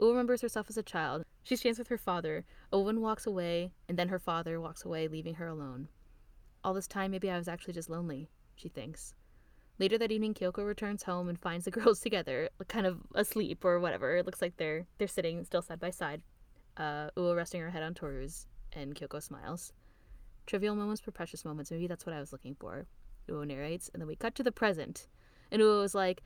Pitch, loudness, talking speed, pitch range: 175 Hz, -35 LUFS, 215 wpm, 155-205 Hz